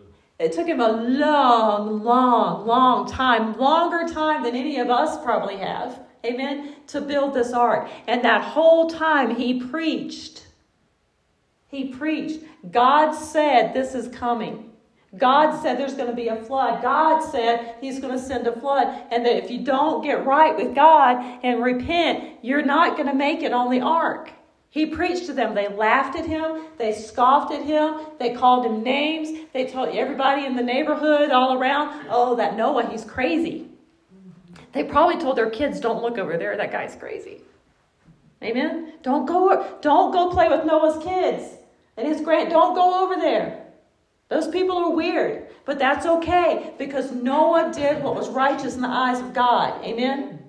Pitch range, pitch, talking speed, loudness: 245-315 Hz, 275 Hz, 175 wpm, -21 LUFS